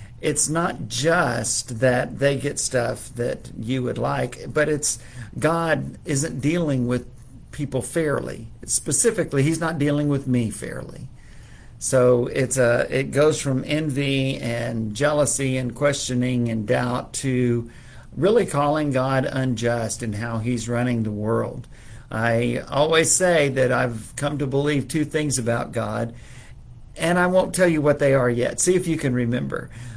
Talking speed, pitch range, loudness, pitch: 150 wpm, 120-145 Hz, -21 LUFS, 130 Hz